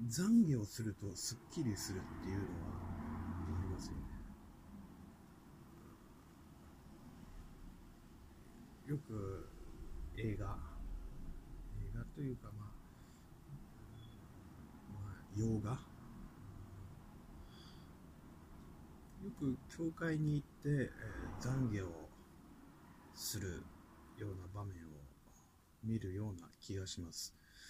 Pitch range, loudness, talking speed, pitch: 80-110 Hz, -43 LUFS, 145 characters per minute, 95 Hz